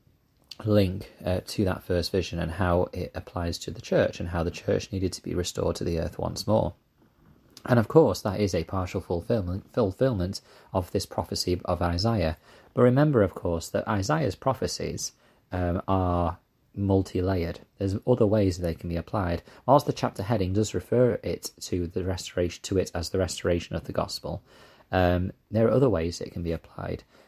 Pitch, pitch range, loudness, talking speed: 95 Hz, 90-110 Hz, -27 LUFS, 185 wpm